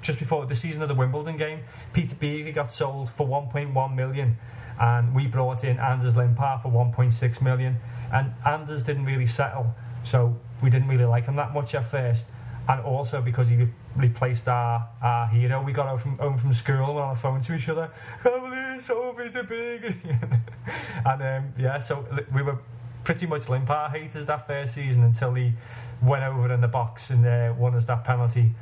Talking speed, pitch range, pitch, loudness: 195 wpm, 120-145 Hz, 130 Hz, -25 LUFS